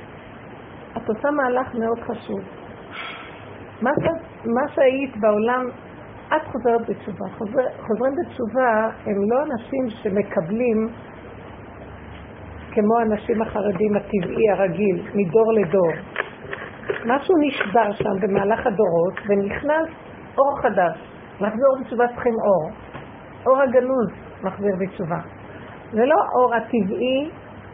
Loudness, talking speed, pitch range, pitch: -21 LUFS, 105 wpm, 200-255 Hz, 225 Hz